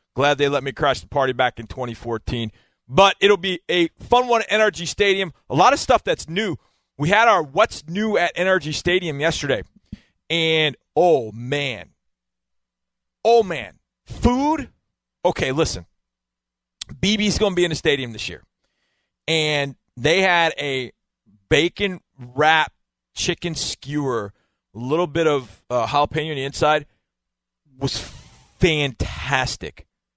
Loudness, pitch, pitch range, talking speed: -20 LUFS, 145 Hz, 115-175 Hz, 140 wpm